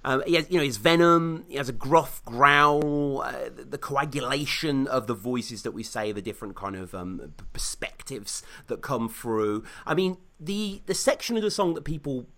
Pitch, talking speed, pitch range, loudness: 140 Hz, 195 wpm, 115-165 Hz, -26 LUFS